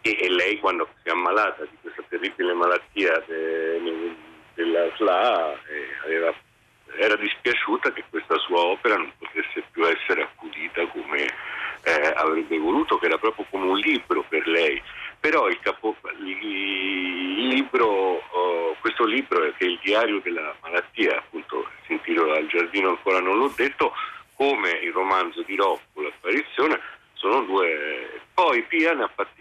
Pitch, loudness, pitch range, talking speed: 370 Hz, -23 LUFS, 315-435 Hz, 155 wpm